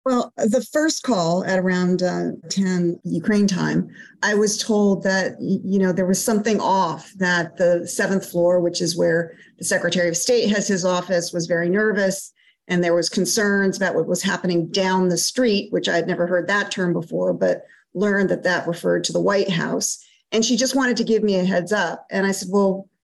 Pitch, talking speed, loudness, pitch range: 190 Hz, 205 wpm, -20 LUFS, 175-205 Hz